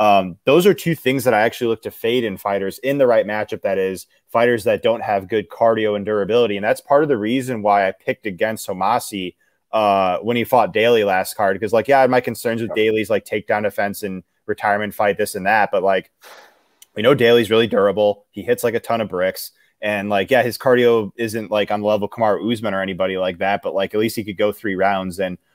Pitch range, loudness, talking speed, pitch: 100-115 Hz, -18 LUFS, 240 wpm, 105 Hz